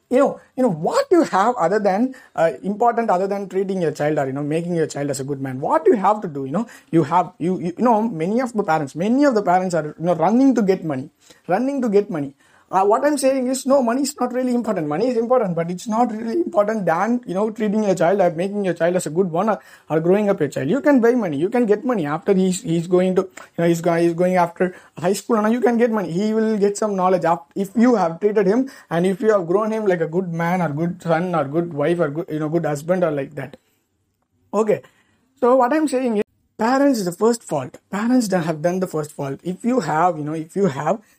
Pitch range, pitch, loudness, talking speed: 165-230 Hz, 190 Hz, -20 LUFS, 270 wpm